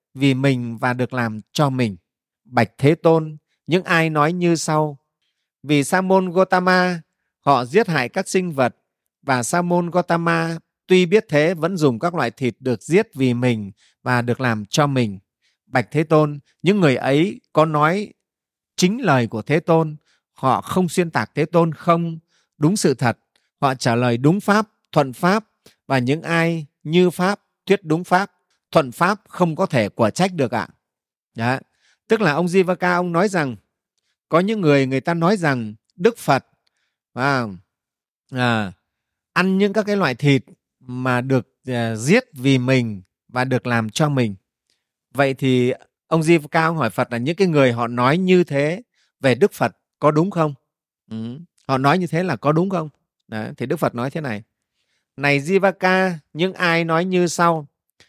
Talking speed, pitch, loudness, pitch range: 180 wpm, 150 Hz, -19 LUFS, 125-175 Hz